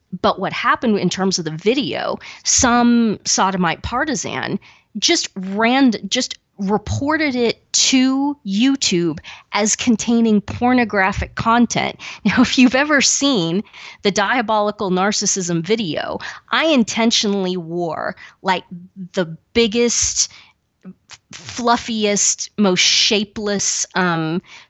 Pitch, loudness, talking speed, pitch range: 210 Hz, -17 LUFS, 100 wpm, 190-240 Hz